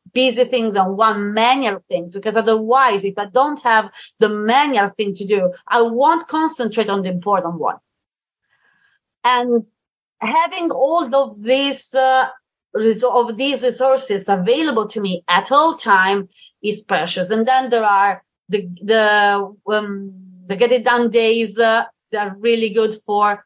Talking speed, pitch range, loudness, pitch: 150 wpm, 200-250 Hz, -17 LUFS, 225 Hz